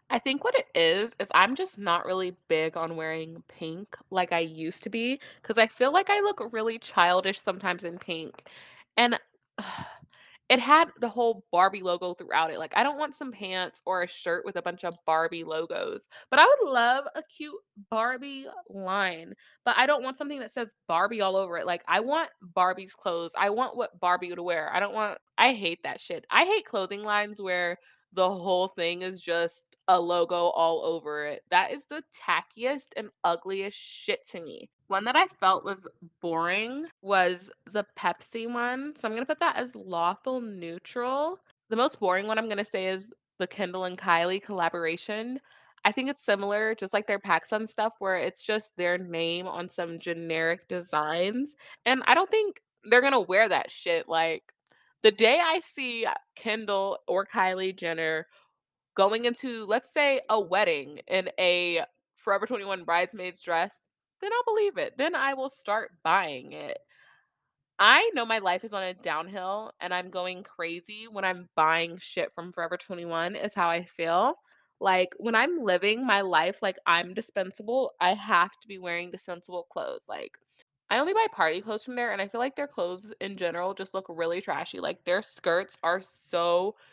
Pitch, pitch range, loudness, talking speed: 195 Hz, 175-245 Hz, -27 LUFS, 185 wpm